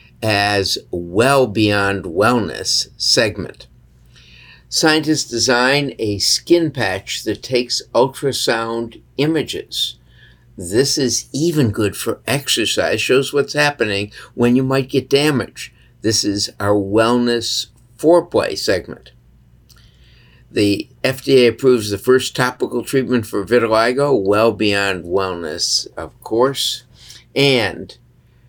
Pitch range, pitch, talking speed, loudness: 105-135 Hz, 120 Hz, 105 wpm, -17 LUFS